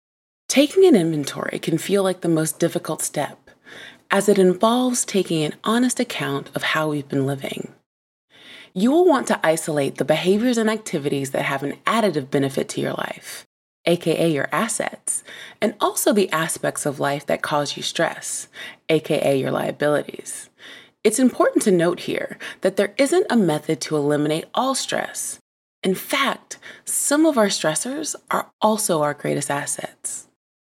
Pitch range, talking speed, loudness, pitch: 155-225 Hz, 155 wpm, -21 LUFS, 175 Hz